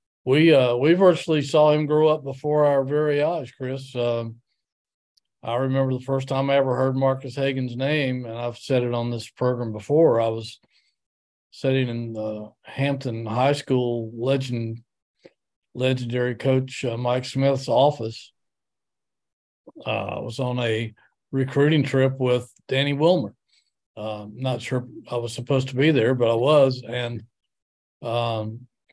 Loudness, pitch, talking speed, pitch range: -23 LUFS, 130 Hz, 150 wpm, 120-135 Hz